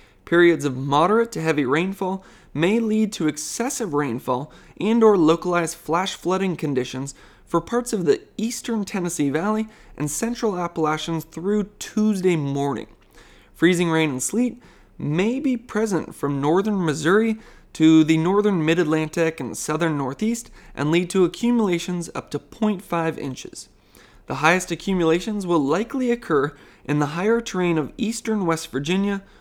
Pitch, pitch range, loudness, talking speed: 175 Hz, 155-215 Hz, -22 LUFS, 140 wpm